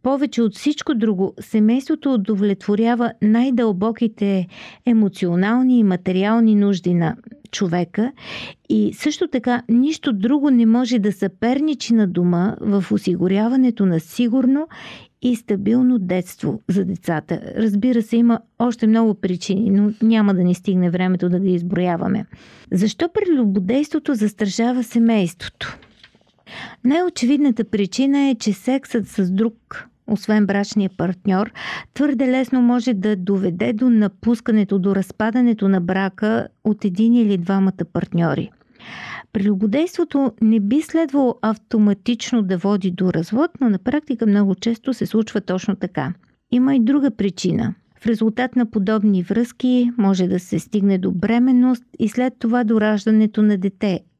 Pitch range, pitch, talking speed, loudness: 195-245 Hz, 220 Hz, 130 wpm, -19 LUFS